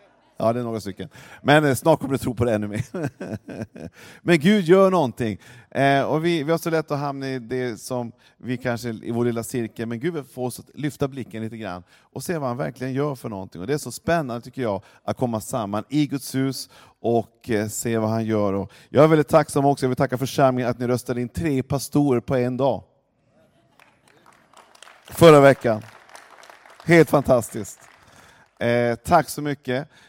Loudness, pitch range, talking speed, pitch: -22 LUFS, 115-145 Hz, 195 wpm, 125 Hz